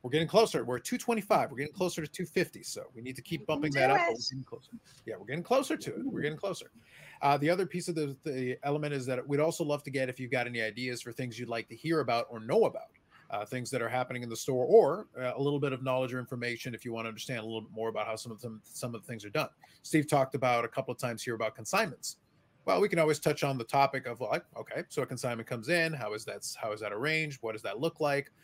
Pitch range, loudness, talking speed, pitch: 120-155 Hz, -32 LUFS, 285 wpm, 135 Hz